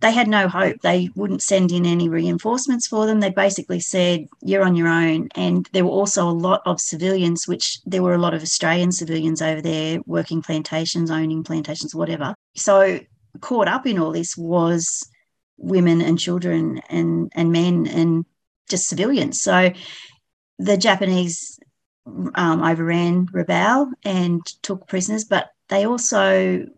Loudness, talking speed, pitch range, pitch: -20 LUFS, 155 wpm, 165-195 Hz, 175 Hz